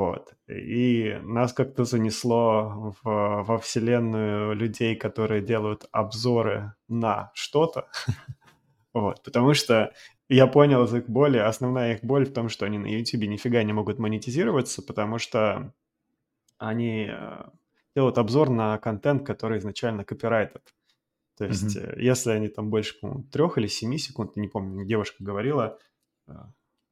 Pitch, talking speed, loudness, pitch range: 115 Hz, 130 wpm, -25 LUFS, 105-125 Hz